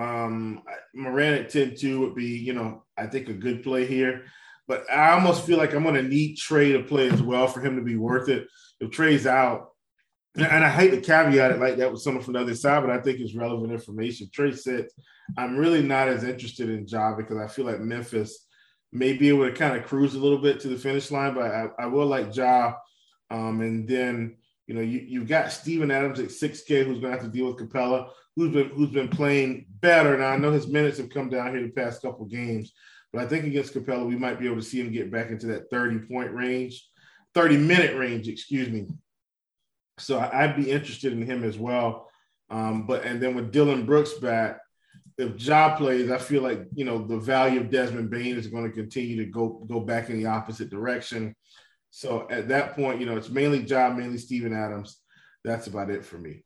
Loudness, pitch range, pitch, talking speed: -25 LUFS, 115-140 Hz, 125 Hz, 230 wpm